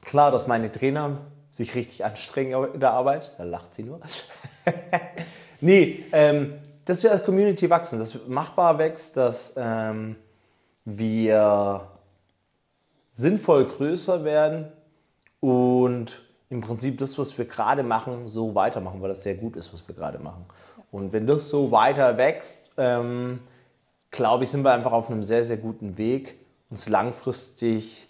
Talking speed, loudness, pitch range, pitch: 145 wpm, -23 LUFS, 110-145 Hz, 125 Hz